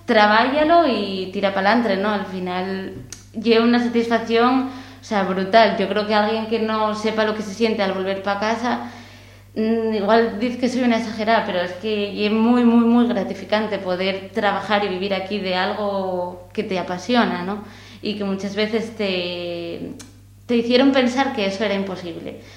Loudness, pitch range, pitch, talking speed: -20 LUFS, 190-225 Hz, 210 Hz, 175 wpm